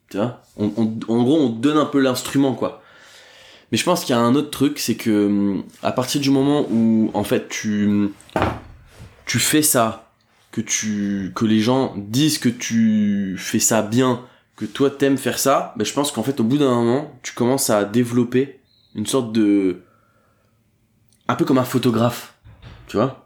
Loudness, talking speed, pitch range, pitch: -19 LUFS, 190 wpm, 110-130 Hz, 115 Hz